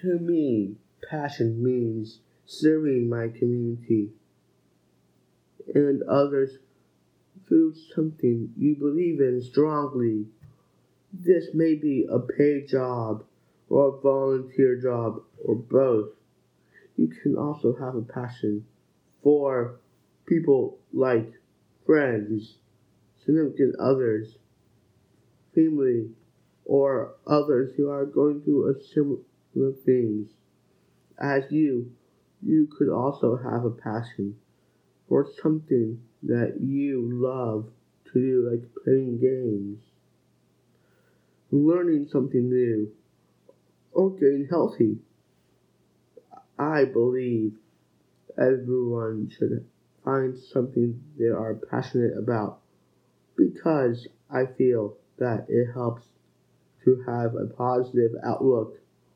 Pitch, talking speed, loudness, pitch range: 125 Hz, 95 wpm, -25 LUFS, 115-140 Hz